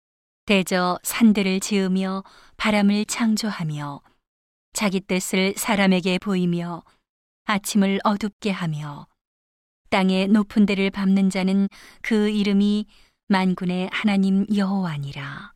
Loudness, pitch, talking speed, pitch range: -22 LUFS, 195 Hz, 230 characters per minute, 185-205 Hz